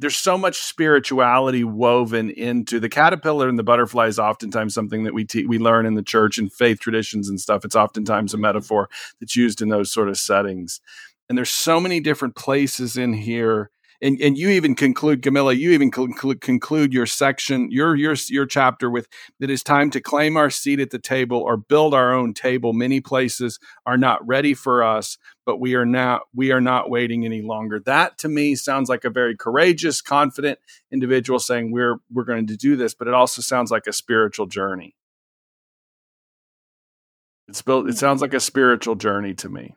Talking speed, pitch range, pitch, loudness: 195 wpm, 115-135 Hz, 125 Hz, -19 LUFS